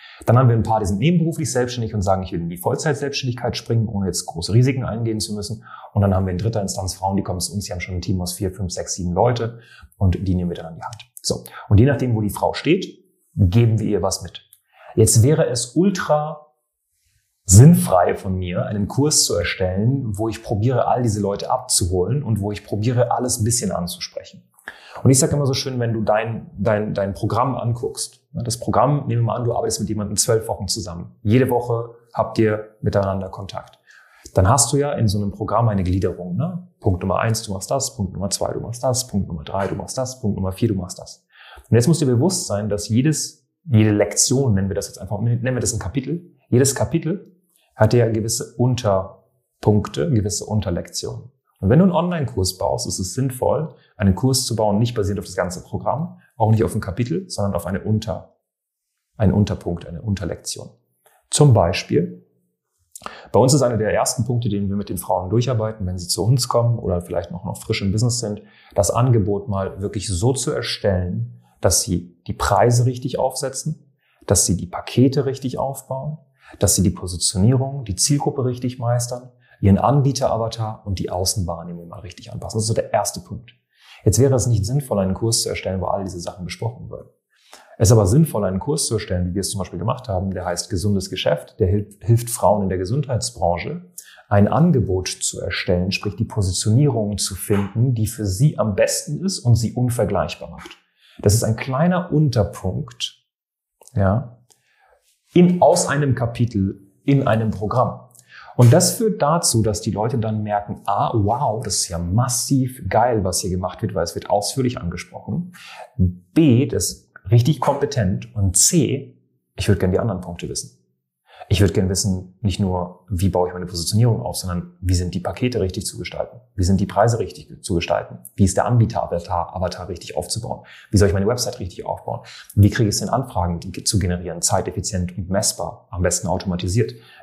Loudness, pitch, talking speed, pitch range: -20 LUFS, 110 Hz, 200 wpm, 95-125 Hz